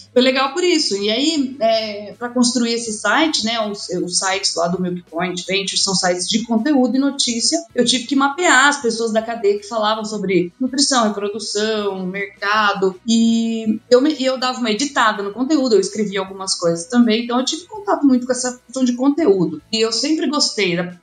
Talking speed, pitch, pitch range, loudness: 195 wpm, 225 Hz, 200-260 Hz, -17 LUFS